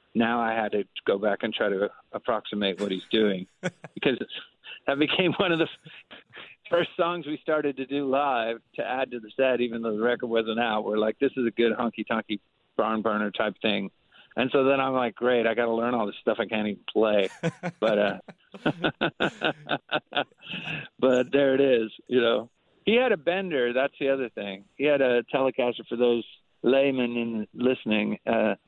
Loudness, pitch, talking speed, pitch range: -26 LUFS, 120 Hz, 190 wpm, 110-135 Hz